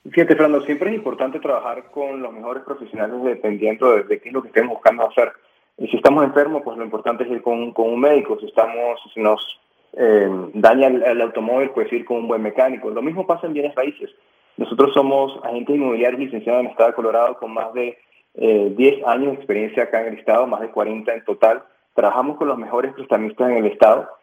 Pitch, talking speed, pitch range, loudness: 120 Hz, 225 wpm, 115-140 Hz, -18 LUFS